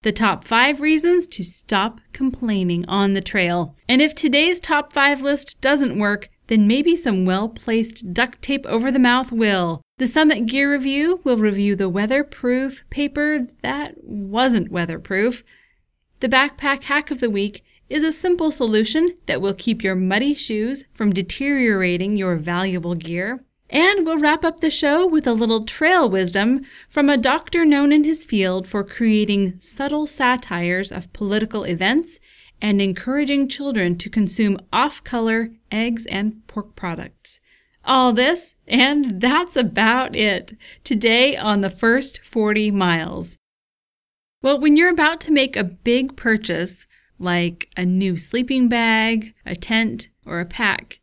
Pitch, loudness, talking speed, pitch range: 235 Hz, -19 LUFS, 150 wpm, 200-280 Hz